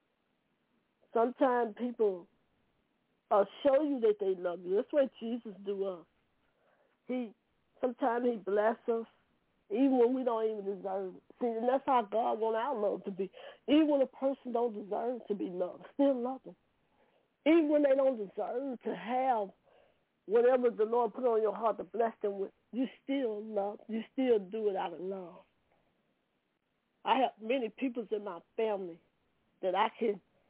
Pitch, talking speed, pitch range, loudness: 230 Hz, 170 wpm, 205-255 Hz, -33 LUFS